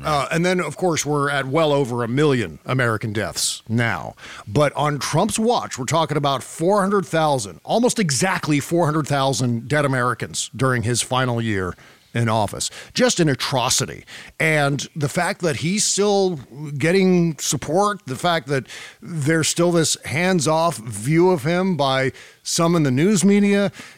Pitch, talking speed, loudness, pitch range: 150 Hz, 155 wpm, -20 LUFS, 130-175 Hz